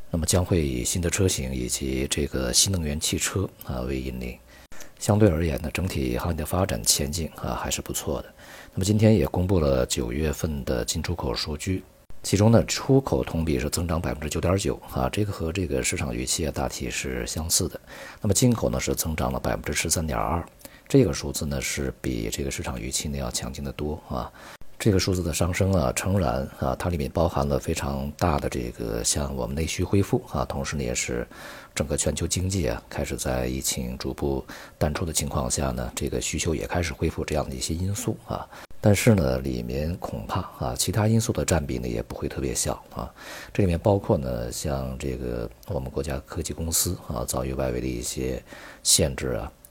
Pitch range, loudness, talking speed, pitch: 65-90 Hz, -26 LUFS, 305 characters per minute, 75 Hz